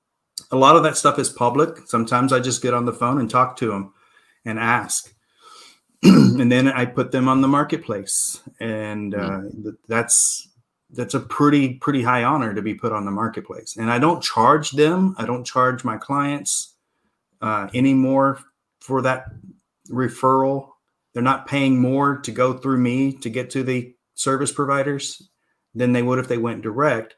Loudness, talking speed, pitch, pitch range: -19 LUFS, 180 wpm, 130 Hz, 120-140 Hz